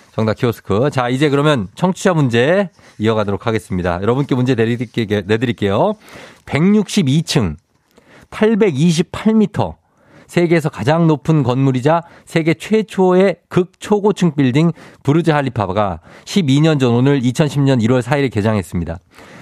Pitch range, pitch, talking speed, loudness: 115-170 Hz, 140 Hz, 270 characters per minute, -16 LUFS